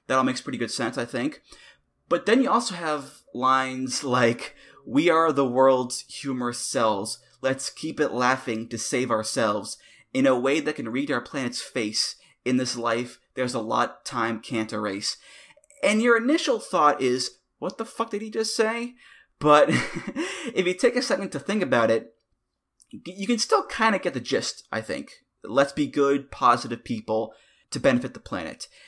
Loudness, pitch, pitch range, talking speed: -25 LUFS, 140 Hz, 125-205 Hz, 180 wpm